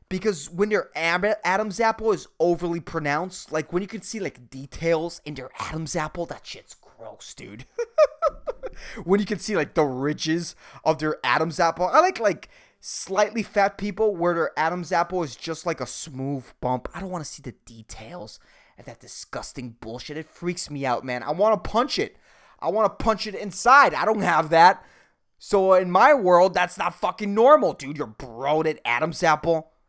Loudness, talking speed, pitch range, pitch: -23 LUFS, 185 wpm, 150-205 Hz, 170 Hz